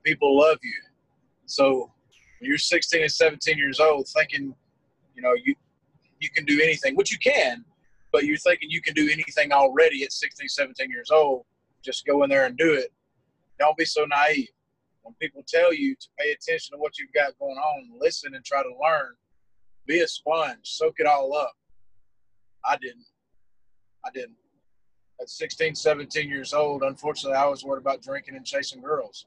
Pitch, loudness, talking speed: 155 Hz, -23 LUFS, 180 wpm